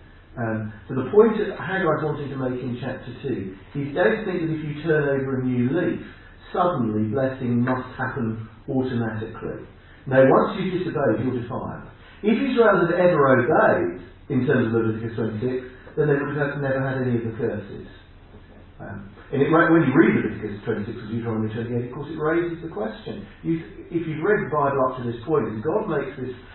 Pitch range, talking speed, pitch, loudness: 115-155 Hz, 190 wpm, 130 Hz, -23 LUFS